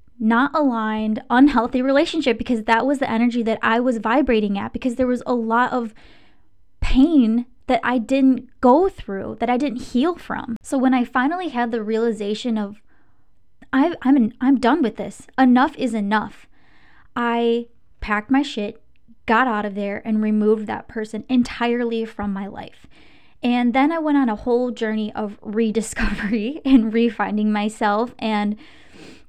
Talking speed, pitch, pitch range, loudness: 160 wpm, 235 Hz, 220-255 Hz, -20 LUFS